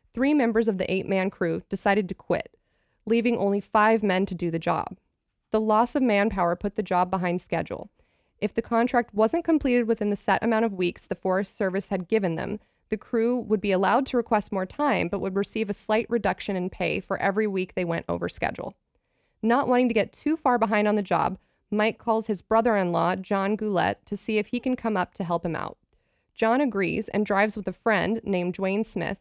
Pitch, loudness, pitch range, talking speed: 210 Hz, -25 LUFS, 190-225 Hz, 215 wpm